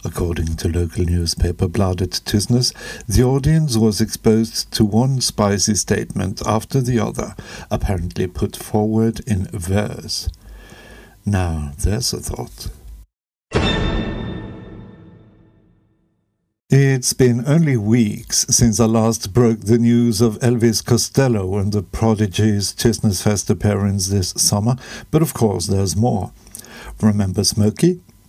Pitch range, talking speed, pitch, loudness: 100-120 Hz, 115 wpm, 110 Hz, -18 LUFS